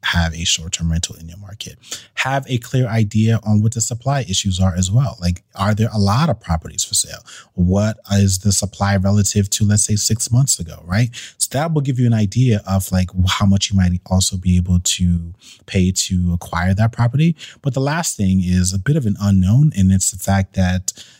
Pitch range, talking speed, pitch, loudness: 95-115 Hz, 220 wpm, 100 Hz, -17 LUFS